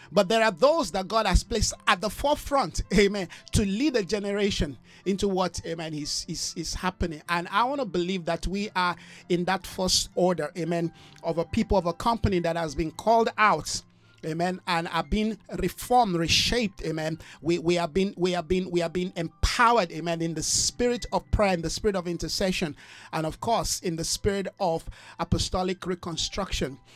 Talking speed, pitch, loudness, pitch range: 190 wpm, 180 Hz, -26 LUFS, 165-205 Hz